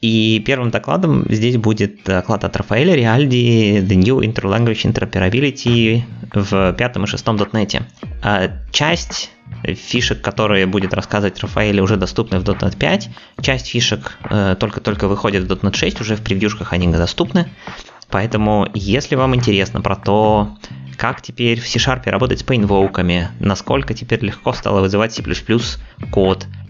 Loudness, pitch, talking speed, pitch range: -16 LUFS, 105 Hz, 135 wpm, 95-115 Hz